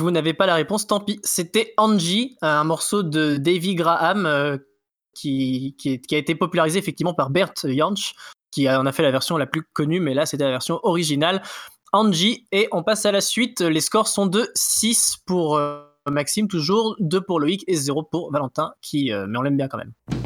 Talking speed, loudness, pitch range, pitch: 215 wpm, -21 LUFS, 145-200 Hz, 165 Hz